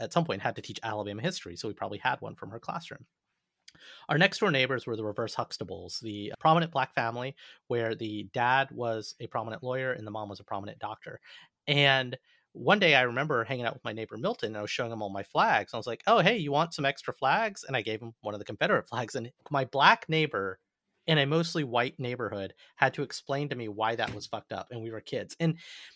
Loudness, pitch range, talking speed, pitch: -30 LUFS, 110-145 Hz, 245 wpm, 125 Hz